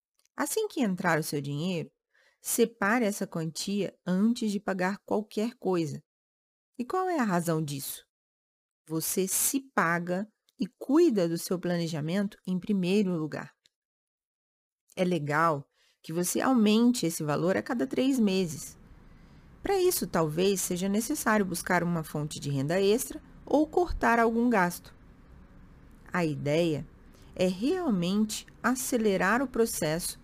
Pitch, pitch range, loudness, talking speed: 185 Hz, 160-230 Hz, -28 LUFS, 125 wpm